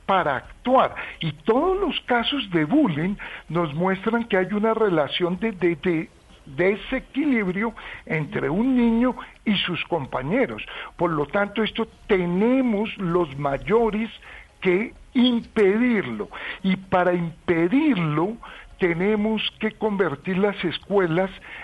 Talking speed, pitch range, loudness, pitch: 115 wpm, 180-230 Hz, -23 LUFS, 200 Hz